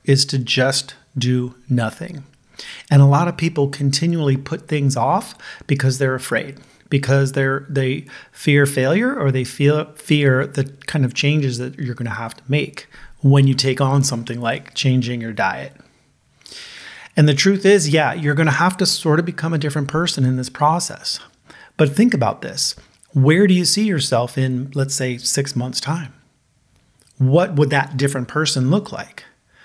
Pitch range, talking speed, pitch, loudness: 130-155 Hz, 175 wpm, 140 Hz, -18 LUFS